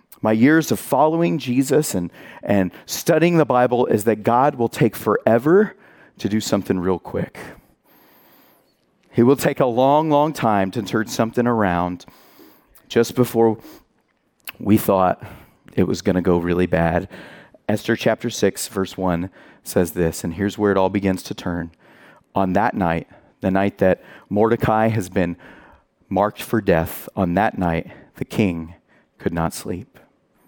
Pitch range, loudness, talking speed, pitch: 90-120 Hz, -20 LUFS, 155 wpm, 105 Hz